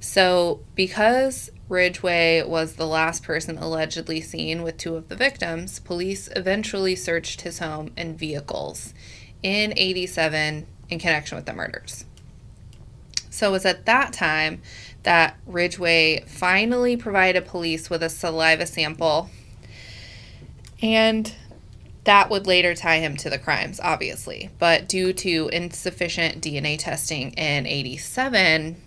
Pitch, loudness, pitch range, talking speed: 170 Hz, -22 LUFS, 160-185 Hz, 125 wpm